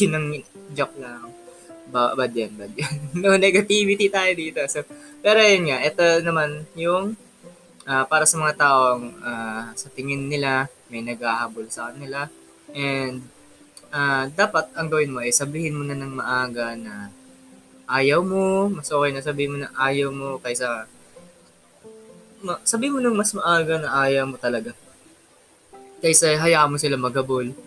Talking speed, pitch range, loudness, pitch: 155 wpm, 125-170 Hz, -21 LUFS, 140 Hz